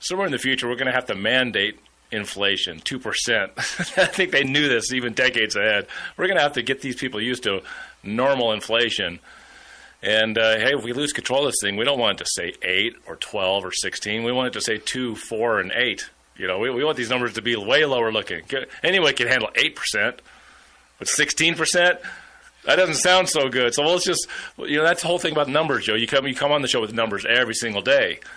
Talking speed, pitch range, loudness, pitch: 230 wpm, 120-160 Hz, -21 LUFS, 130 Hz